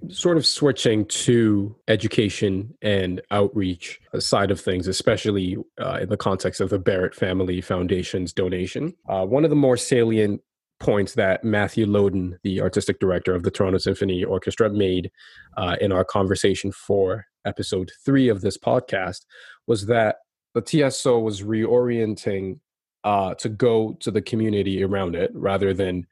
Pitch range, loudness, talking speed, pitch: 95-115 Hz, -22 LUFS, 150 wpm, 100 Hz